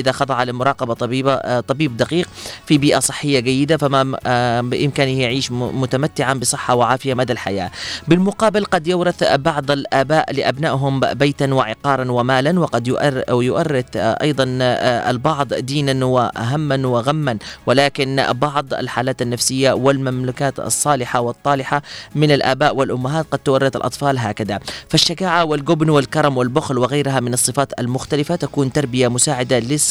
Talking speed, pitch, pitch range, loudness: 120 wpm, 135 Hz, 125-145 Hz, -17 LUFS